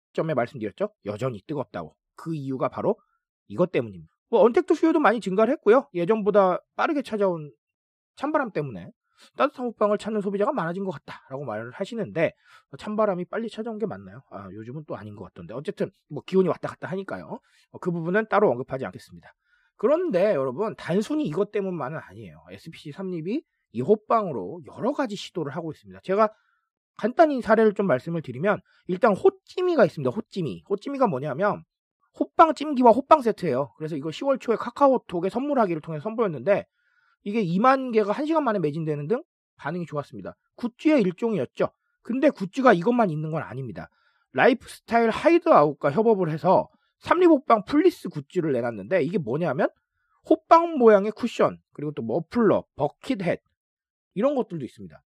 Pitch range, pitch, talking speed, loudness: 160-250 Hz, 205 Hz, 390 characters per minute, -24 LUFS